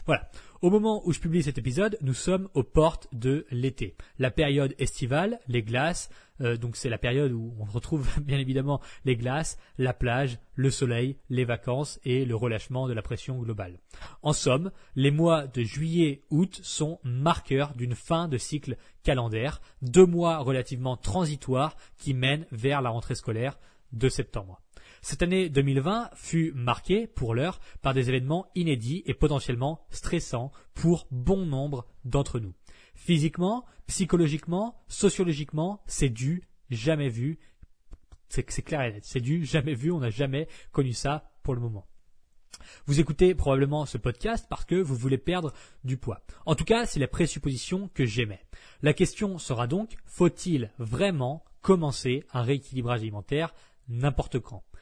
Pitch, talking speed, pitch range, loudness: 140 Hz, 160 wpm, 125-165 Hz, -28 LUFS